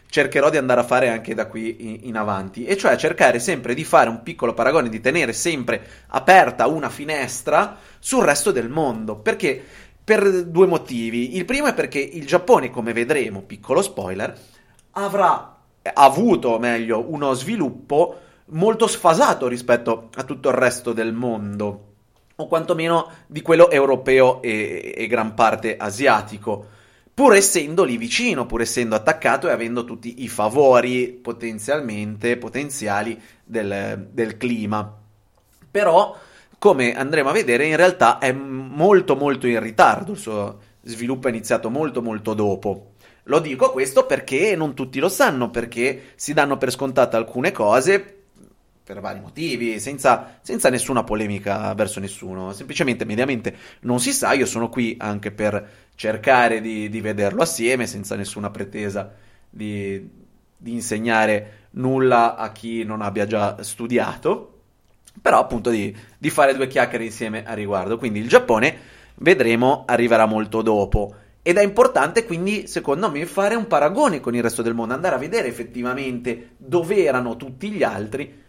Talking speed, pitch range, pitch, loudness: 150 wpm, 110-140 Hz, 120 Hz, -20 LUFS